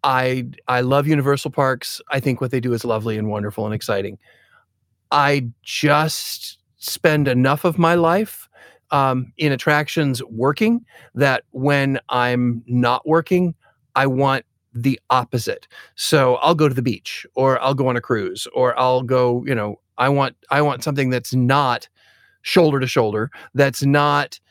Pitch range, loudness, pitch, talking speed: 125-150 Hz, -19 LUFS, 135 Hz, 160 wpm